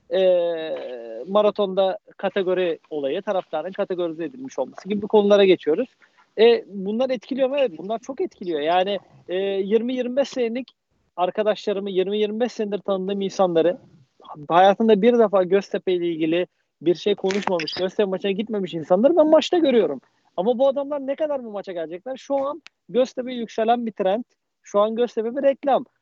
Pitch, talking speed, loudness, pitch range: 205 Hz, 145 wpm, -22 LUFS, 185-250 Hz